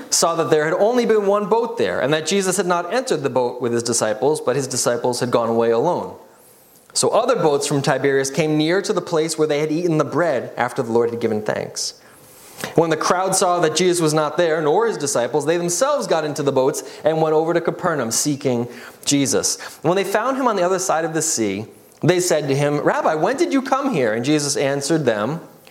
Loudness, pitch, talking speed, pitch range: -19 LUFS, 155 Hz, 230 wpm, 140-180 Hz